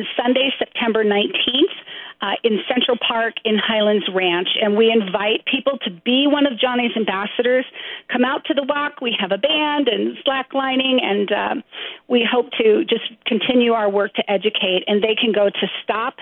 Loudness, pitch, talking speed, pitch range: -18 LUFS, 235 Hz, 180 wpm, 210-265 Hz